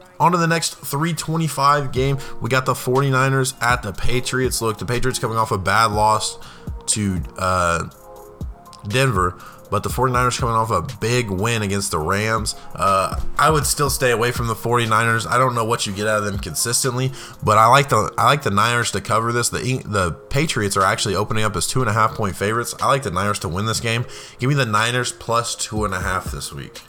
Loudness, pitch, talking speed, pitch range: -19 LUFS, 115 Hz, 220 wpm, 105-130 Hz